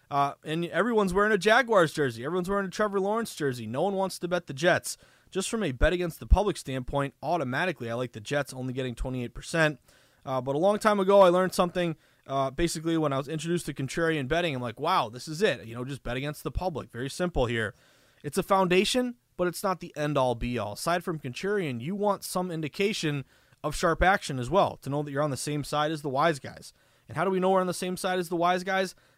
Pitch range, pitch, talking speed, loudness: 135-185 Hz, 160 Hz, 245 wpm, -28 LUFS